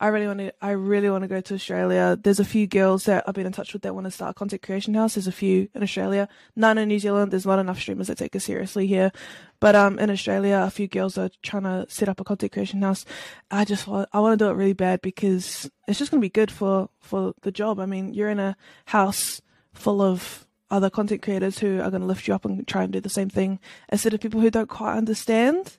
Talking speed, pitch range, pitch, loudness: 270 wpm, 190-210 Hz, 195 Hz, -24 LUFS